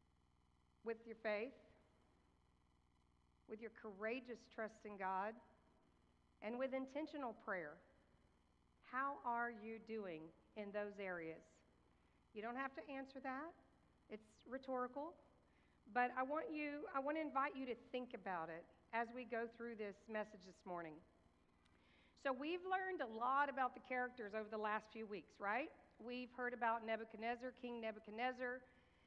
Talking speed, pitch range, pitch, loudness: 140 wpm, 165-250 Hz, 225 Hz, -47 LUFS